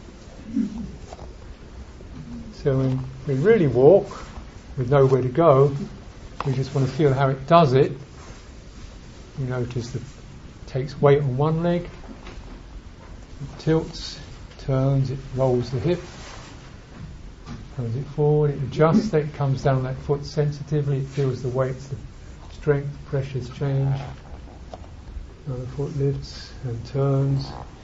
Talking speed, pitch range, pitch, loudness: 130 wpm, 120-145 Hz, 135 Hz, -22 LUFS